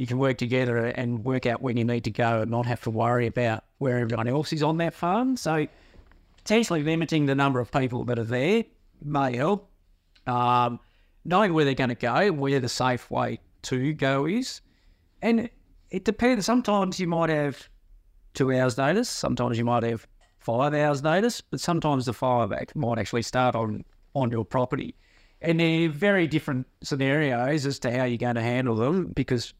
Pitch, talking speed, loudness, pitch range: 130 Hz, 190 wpm, -25 LUFS, 120-155 Hz